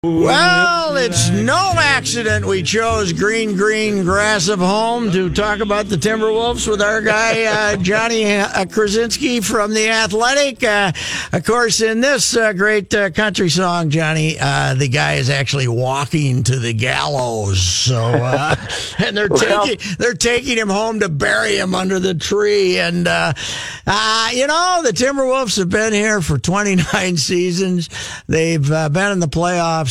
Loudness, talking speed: -15 LUFS, 160 wpm